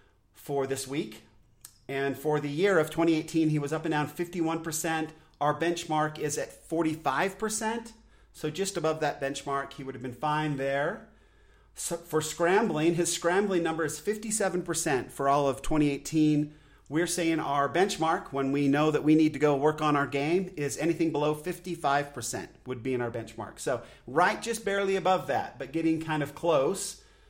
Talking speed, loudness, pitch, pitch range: 175 wpm, -29 LUFS, 155 Hz, 140-170 Hz